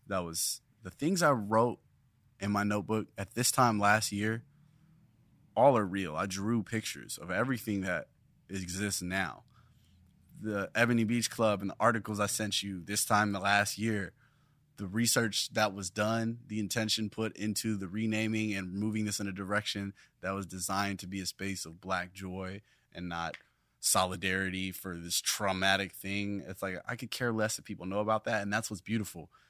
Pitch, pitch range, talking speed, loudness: 105 Hz, 95-110 Hz, 180 wpm, -32 LUFS